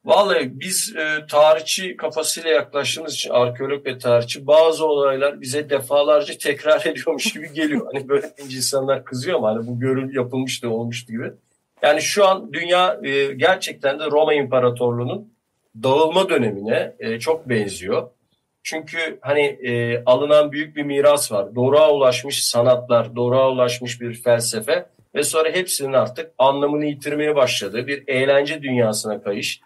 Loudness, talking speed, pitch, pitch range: -19 LUFS, 135 wpm, 140 Hz, 125-155 Hz